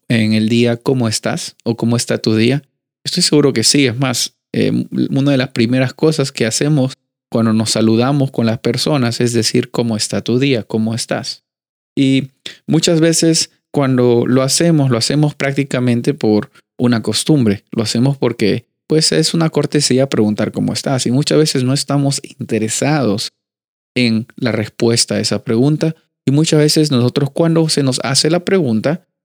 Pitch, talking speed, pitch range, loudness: 130 Hz, 170 wpm, 115-145 Hz, -15 LUFS